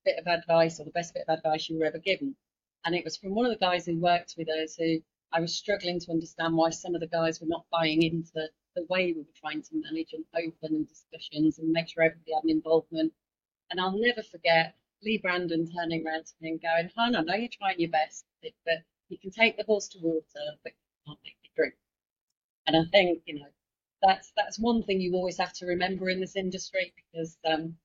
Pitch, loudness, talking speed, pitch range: 170 Hz, -29 LUFS, 235 wpm, 160-190 Hz